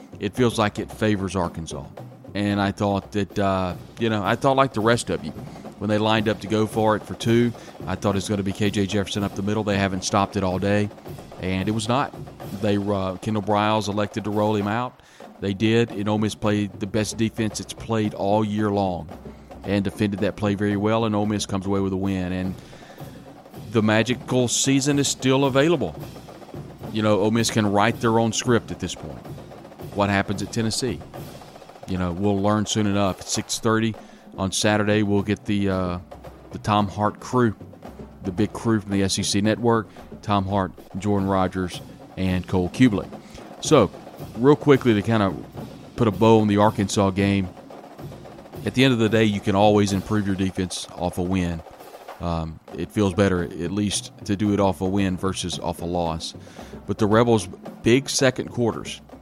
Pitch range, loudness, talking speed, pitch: 95-110 Hz, -22 LUFS, 195 wpm, 105 Hz